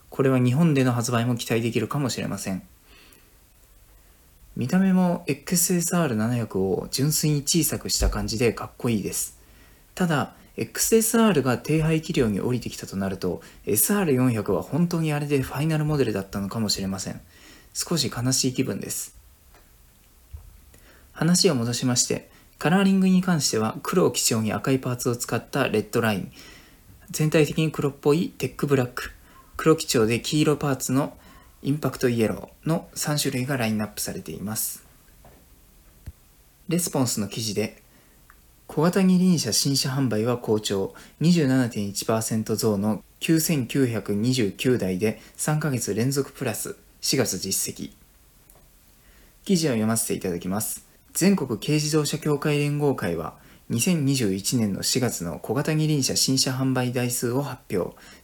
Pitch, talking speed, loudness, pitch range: 130 Hz, 280 characters per minute, -24 LUFS, 105-150 Hz